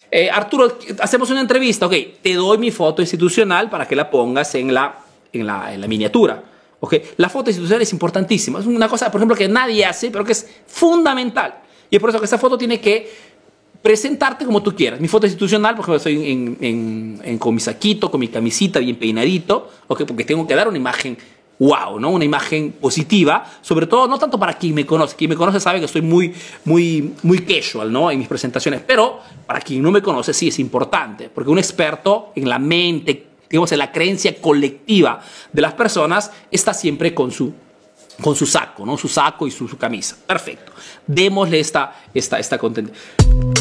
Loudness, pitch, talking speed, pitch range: -17 LUFS, 185 Hz, 200 wpm, 155-220 Hz